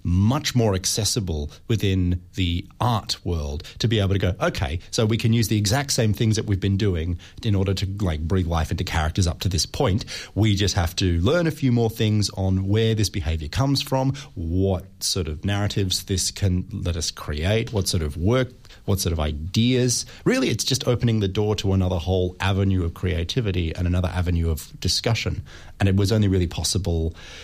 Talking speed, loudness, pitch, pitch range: 200 wpm, -23 LUFS, 95 Hz, 90-110 Hz